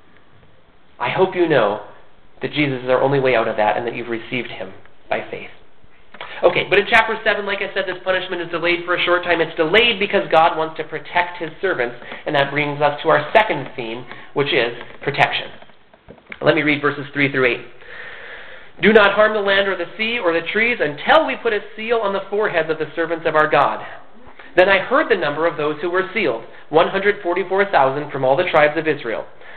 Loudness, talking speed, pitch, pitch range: -18 LUFS, 215 wpm, 165 Hz, 140-195 Hz